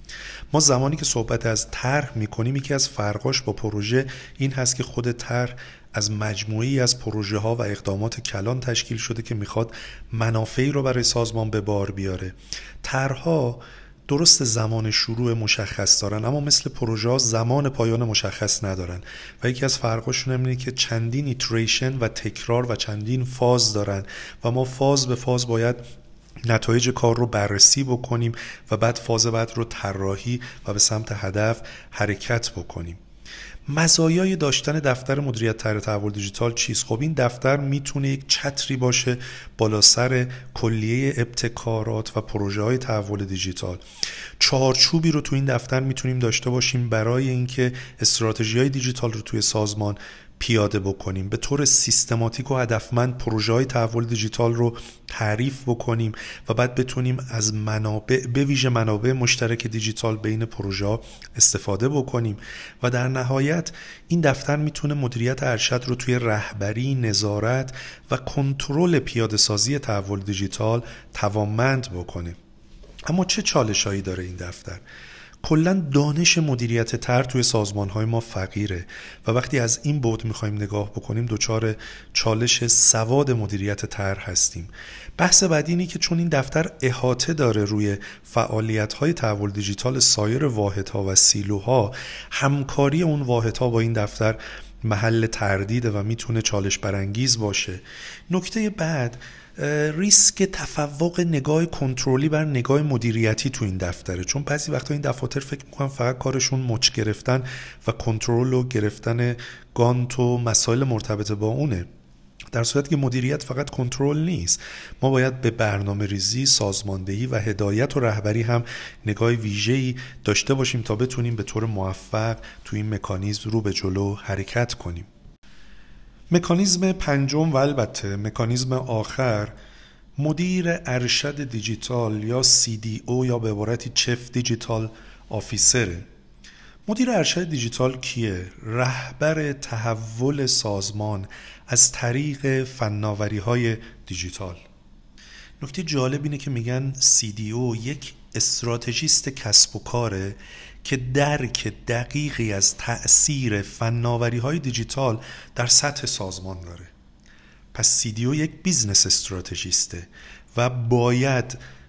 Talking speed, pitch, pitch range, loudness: 135 wpm, 120 Hz, 105-130 Hz, -22 LUFS